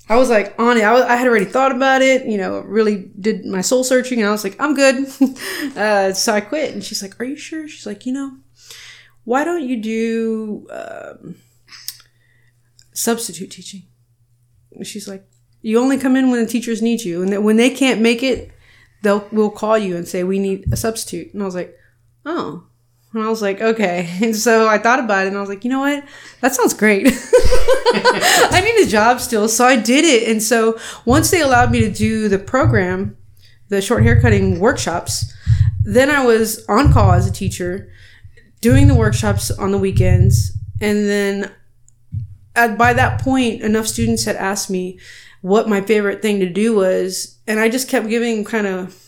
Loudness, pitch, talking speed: -16 LUFS, 210 Hz, 200 wpm